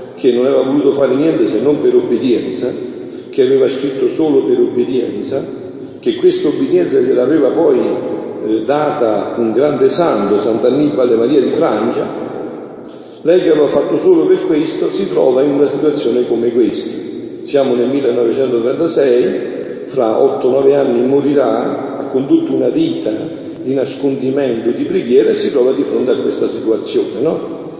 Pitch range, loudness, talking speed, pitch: 330-395 Hz, -14 LUFS, 150 wpm, 365 Hz